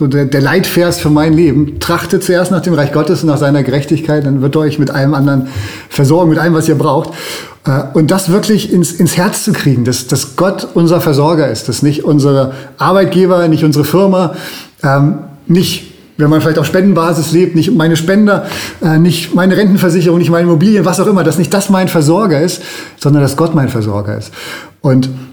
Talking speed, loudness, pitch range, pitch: 195 wpm, -11 LUFS, 145-180 Hz, 165 Hz